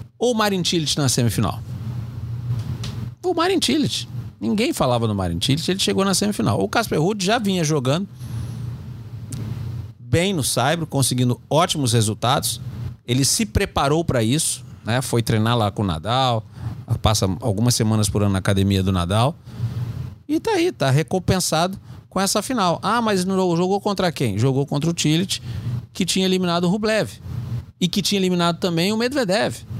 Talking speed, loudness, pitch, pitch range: 160 wpm, -21 LUFS, 125 Hz, 115-185 Hz